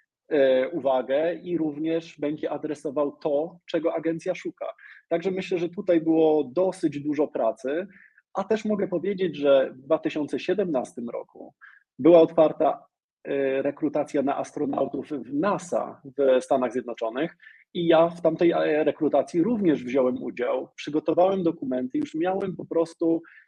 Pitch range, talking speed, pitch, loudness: 145-175 Hz, 125 wpm, 160 Hz, -25 LUFS